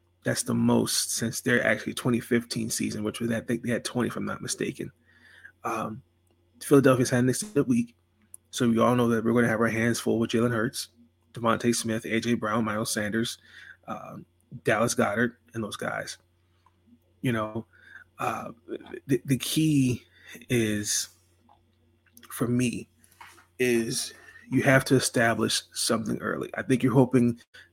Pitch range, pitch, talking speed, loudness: 105-125 Hz, 115 Hz, 155 wpm, -26 LUFS